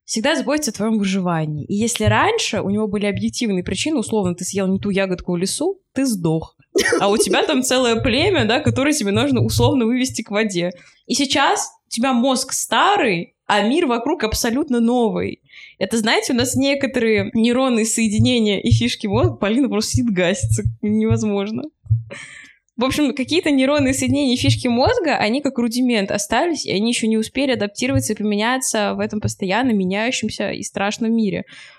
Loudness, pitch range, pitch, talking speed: -18 LUFS, 200-260 Hz, 225 Hz, 170 wpm